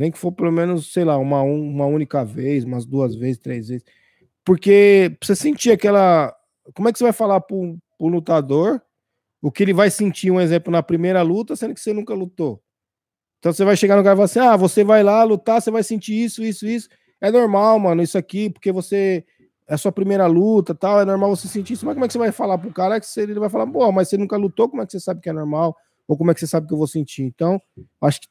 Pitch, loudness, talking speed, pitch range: 185 Hz, -18 LUFS, 265 wpm, 160-210 Hz